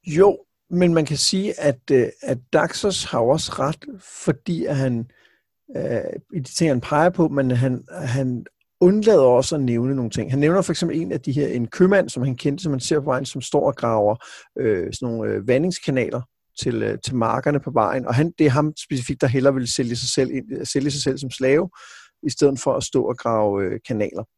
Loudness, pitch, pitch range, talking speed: -21 LUFS, 140 Hz, 125-155 Hz, 215 wpm